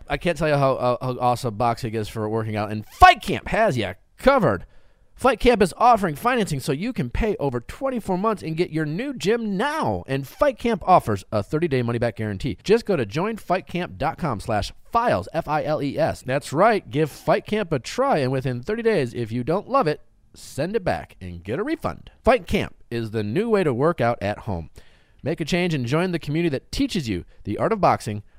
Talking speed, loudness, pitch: 205 wpm, -23 LUFS, 145 Hz